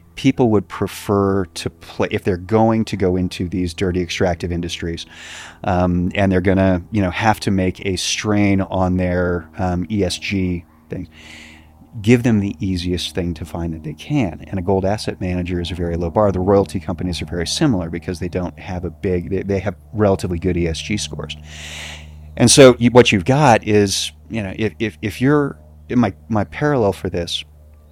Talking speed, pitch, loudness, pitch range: 195 wpm, 90 Hz, -18 LUFS, 85-105 Hz